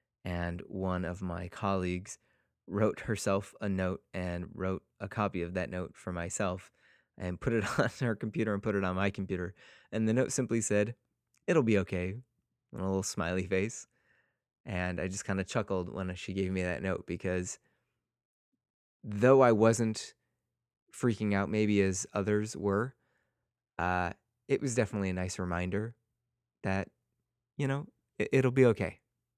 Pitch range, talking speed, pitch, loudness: 90-110 Hz, 160 wpm, 100 Hz, -32 LUFS